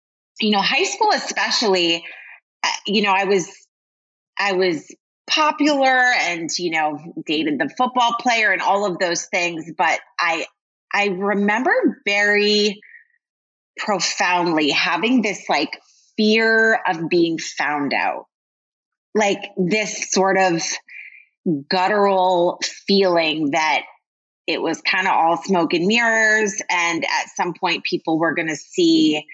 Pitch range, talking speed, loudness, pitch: 170-220 Hz, 125 wpm, -18 LUFS, 195 Hz